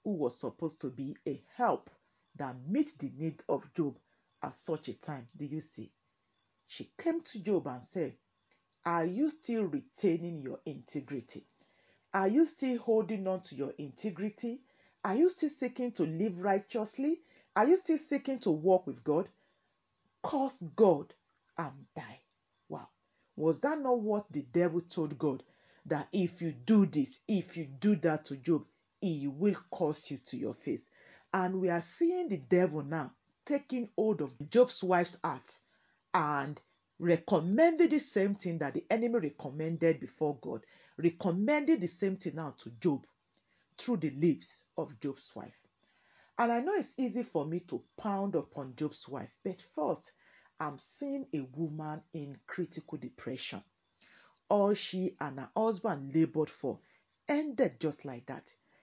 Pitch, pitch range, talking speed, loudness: 175 Hz, 150-225 Hz, 160 wpm, -34 LUFS